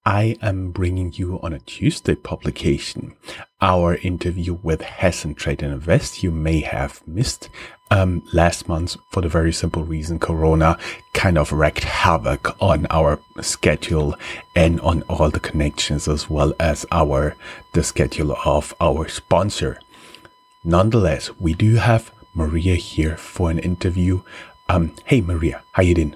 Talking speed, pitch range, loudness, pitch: 145 wpm, 80-90 Hz, -20 LUFS, 85 Hz